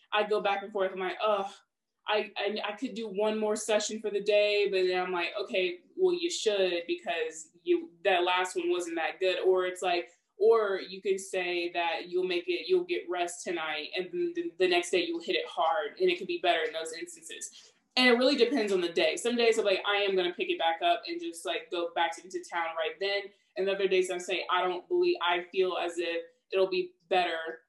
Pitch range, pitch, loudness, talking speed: 180-235 Hz, 195 Hz, -29 LUFS, 240 wpm